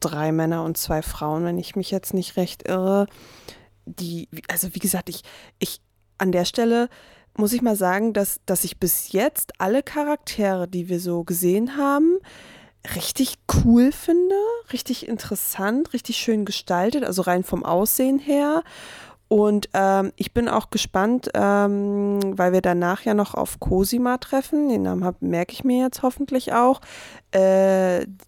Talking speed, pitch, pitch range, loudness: 155 wpm, 200 Hz, 180-245 Hz, -22 LUFS